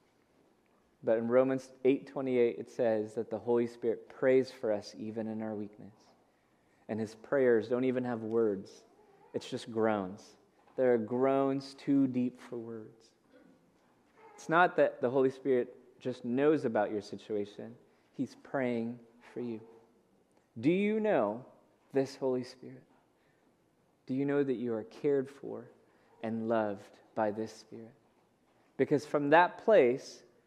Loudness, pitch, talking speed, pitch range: -32 LUFS, 120 Hz, 140 wpm, 110-135 Hz